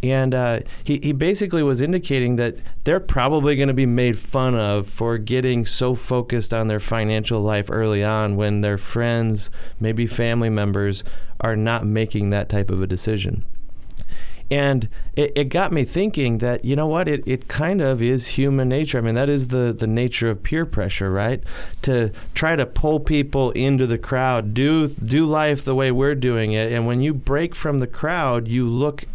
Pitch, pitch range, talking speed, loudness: 125 Hz, 110-140 Hz, 190 wpm, -21 LUFS